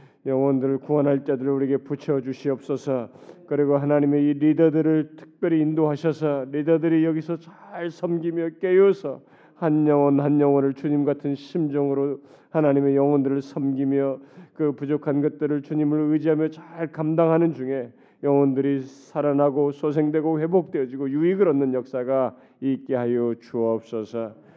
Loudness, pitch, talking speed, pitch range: -23 LUFS, 145 Hz, 330 characters per minute, 135-155 Hz